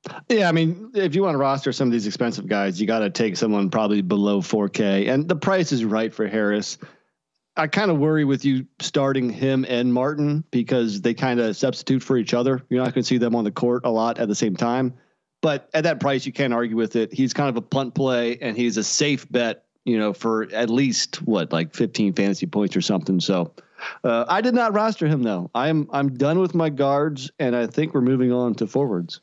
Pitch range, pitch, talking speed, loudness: 110-140 Hz, 125 Hz, 235 wpm, -22 LUFS